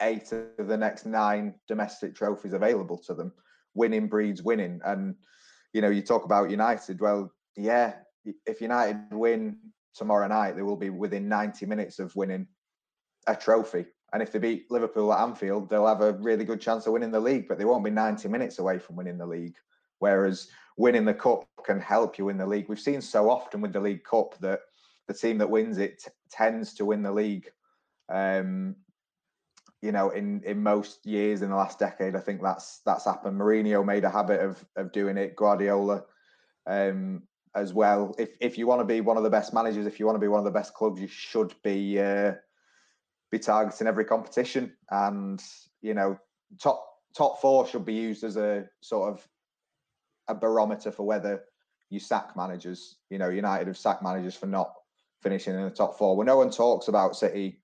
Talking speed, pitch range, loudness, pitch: 200 wpm, 100-110 Hz, -28 LUFS, 105 Hz